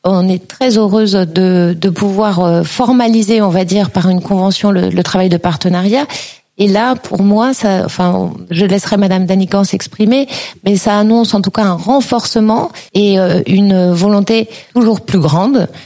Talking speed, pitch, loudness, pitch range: 165 wpm, 200 Hz, -11 LUFS, 185-220 Hz